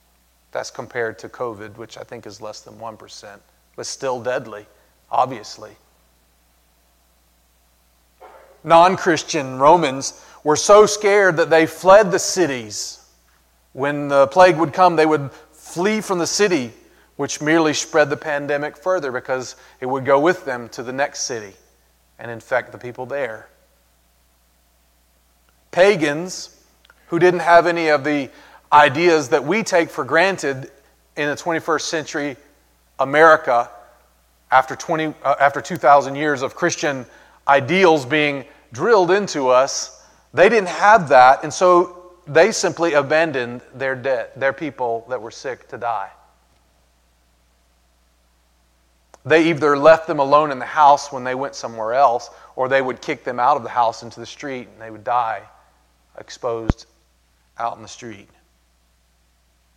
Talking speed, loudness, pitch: 140 wpm, -17 LUFS, 135 Hz